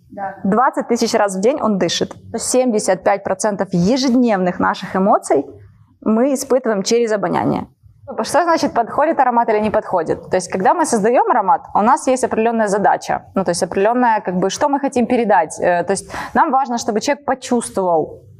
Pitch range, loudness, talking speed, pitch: 195-255 Hz, -16 LUFS, 165 wpm, 225 Hz